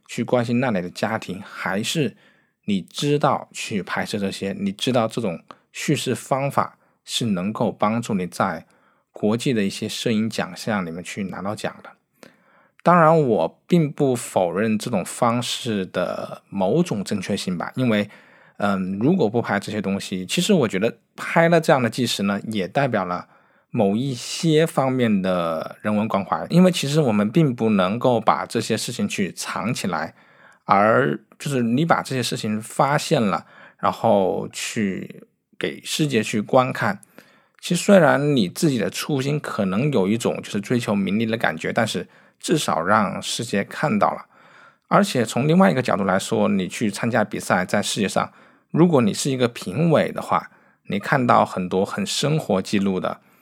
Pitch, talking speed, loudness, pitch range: 120 Hz, 250 characters per minute, -21 LUFS, 105-155 Hz